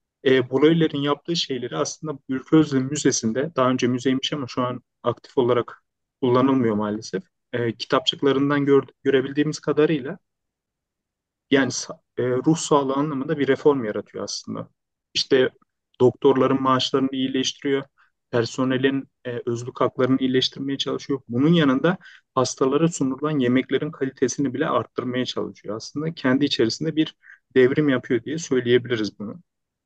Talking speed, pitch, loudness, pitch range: 120 wpm, 135 Hz, -22 LUFS, 125-145 Hz